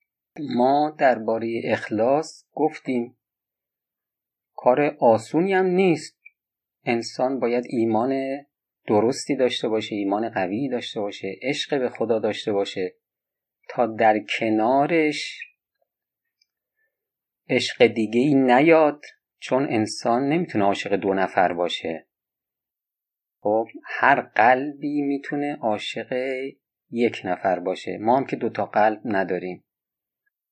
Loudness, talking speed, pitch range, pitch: -22 LUFS, 100 wpm, 110-145 Hz, 125 Hz